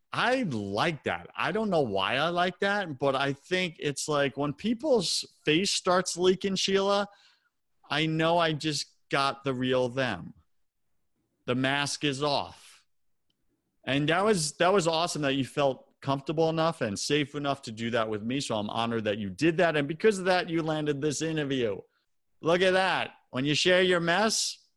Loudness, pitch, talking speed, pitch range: -28 LUFS, 150 Hz, 180 wpm, 135-180 Hz